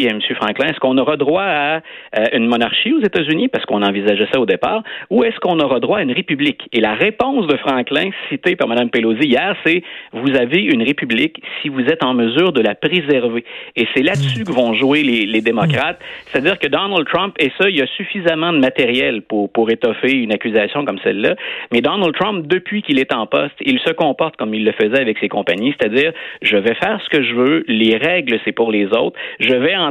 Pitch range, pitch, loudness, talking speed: 115-180 Hz, 140 Hz, -16 LUFS, 225 wpm